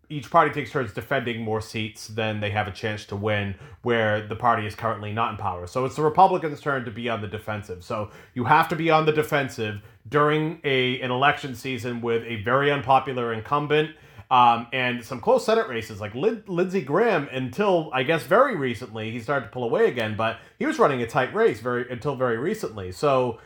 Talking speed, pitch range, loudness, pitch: 210 wpm, 110-145 Hz, -24 LUFS, 125 Hz